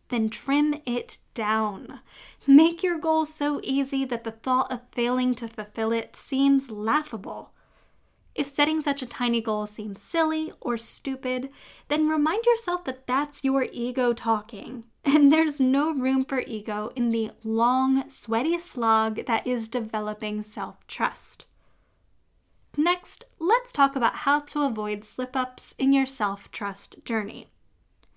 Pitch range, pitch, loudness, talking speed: 225-290 Hz, 255 Hz, -25 LUFS, 145 wpm